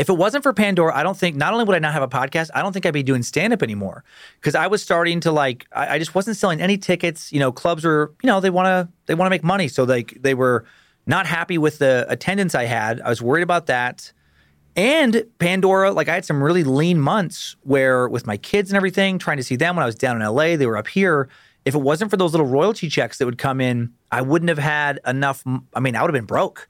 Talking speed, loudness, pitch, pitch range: 265 wpm, -19 LUFS, 155 Hz, 130-185 Hz